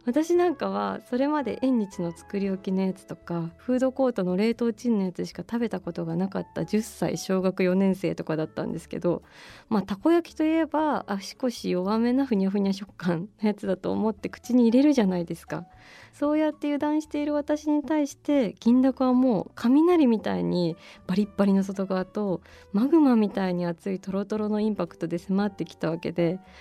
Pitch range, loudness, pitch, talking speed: 185-260 Hz, -26 LUFS, 205 Hz, 390 characters per minute